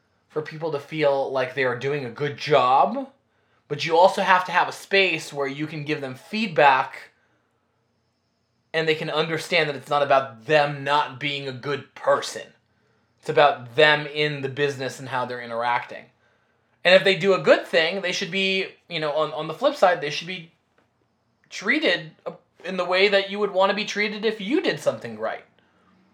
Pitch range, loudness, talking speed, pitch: 135-185 Hz, -22 LUFS, 195 wpm, 150 Hz